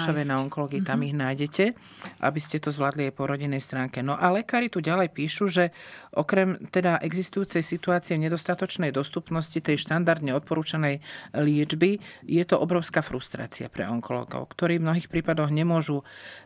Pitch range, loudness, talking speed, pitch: 145-175 Hz, -26 LUFS, 155 wpm, 160 Hz